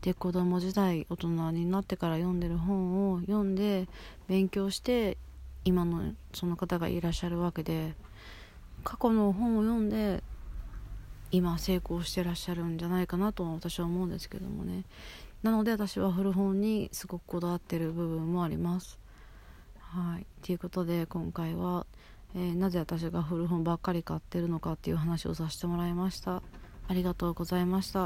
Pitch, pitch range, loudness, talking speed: 175 Hz, 170-190 Hz, -32 LUFS, 340 characters per minute